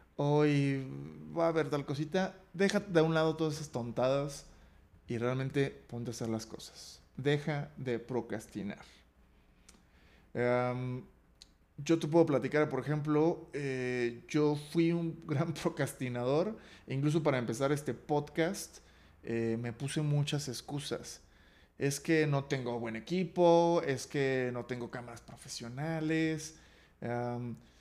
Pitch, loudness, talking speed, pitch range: 140 Hz, -33 LUFS, 130 wpm, 120-155 Hz